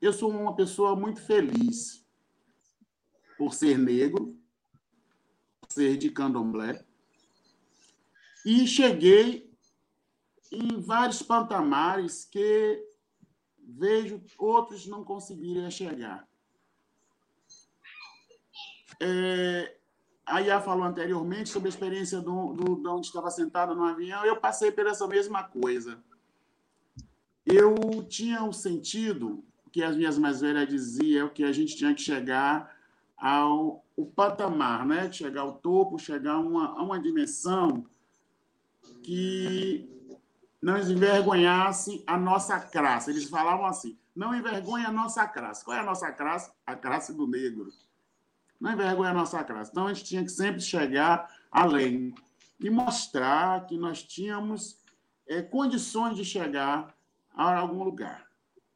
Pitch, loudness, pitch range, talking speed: 190 Hz, -28 LUFS, 165-225 Hz, 125 wpm